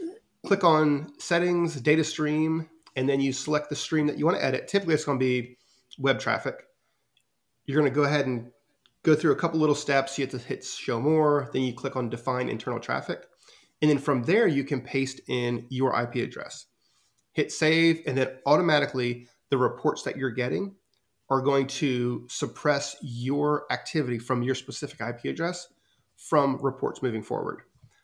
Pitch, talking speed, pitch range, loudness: 140 Hz, 180 wpm, 130-155 Hz, -27 LUFS